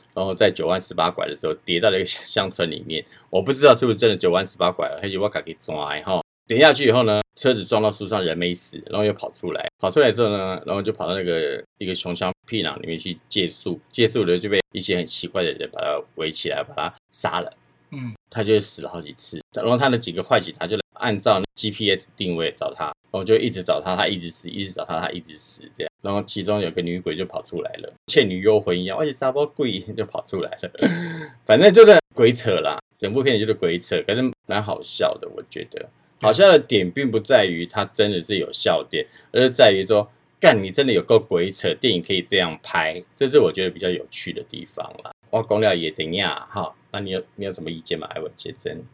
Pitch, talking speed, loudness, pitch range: 105 Hz, 340 characters per minute, -20 LUFS, 90-130 Hz